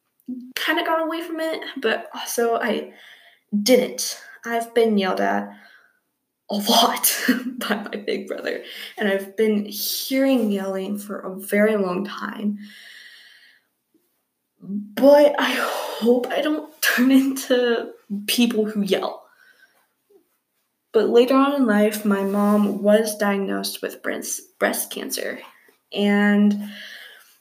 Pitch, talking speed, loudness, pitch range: 230 Hz, 115 wpm, -21 LUFS, 205-275 Hz